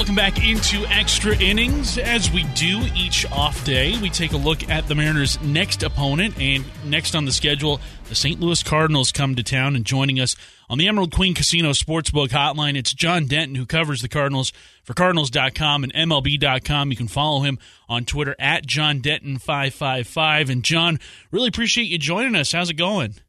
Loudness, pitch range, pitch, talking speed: -19 LUFS, 135-160 Hz, 145 Hz, 185 wpm